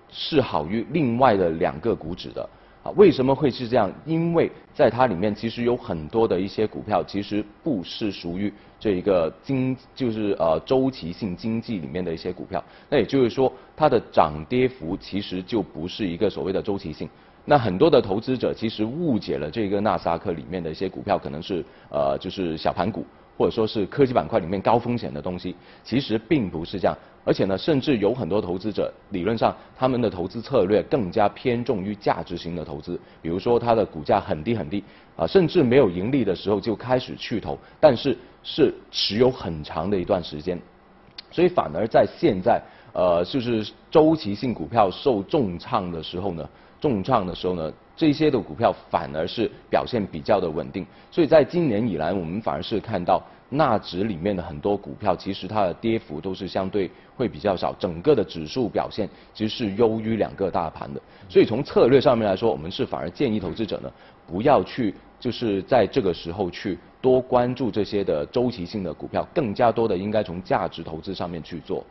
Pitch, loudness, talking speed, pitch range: 105 Hz, -24 LUFS, 305 characters per minute, 90-120 Hz